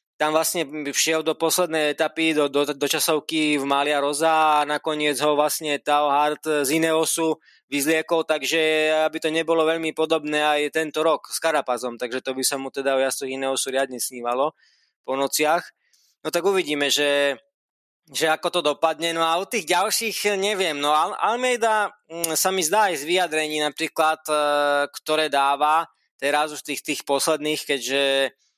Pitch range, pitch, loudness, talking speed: 145-160 Hz, 155 Hz, -22 LUFS, 160 wpm